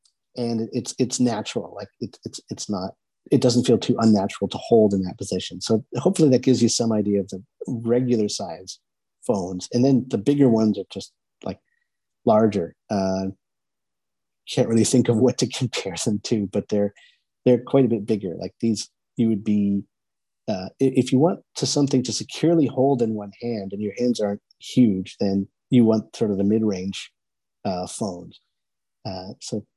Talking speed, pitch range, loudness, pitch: 180 wpm, 100-125 Hz, -22 LUFS, 115 Hz